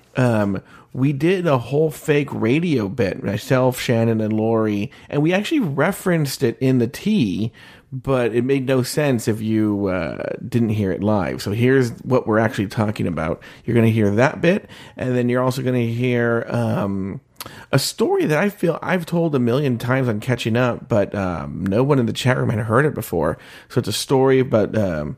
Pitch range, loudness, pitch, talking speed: 110-135 Hz, -20 LUFS, 120 Hz, 195 wpm